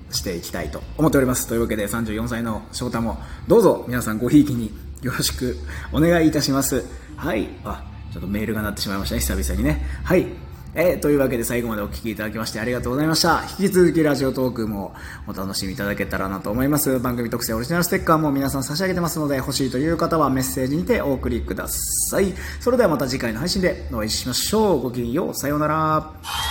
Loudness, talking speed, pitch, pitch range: -21 LUFS, 485 characters per minute, 120 Hz, 100-145 Hz